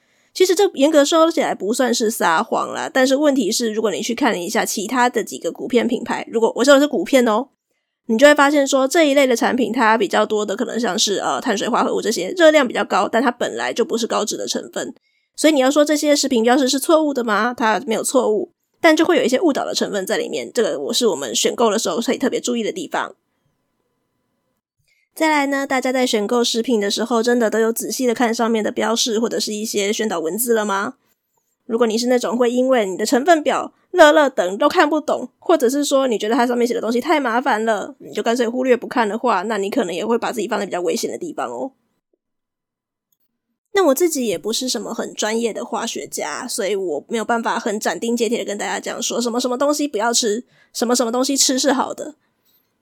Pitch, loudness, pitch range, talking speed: 240 Hz, -18 LUFS, 225-285 Hz, 345 characters per minute